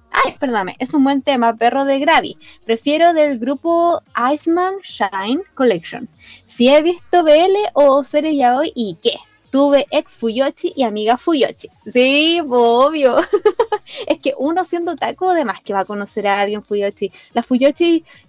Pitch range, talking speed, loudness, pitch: 235-335 Hz, 160 wpm, -16 LUFS, 280 Hz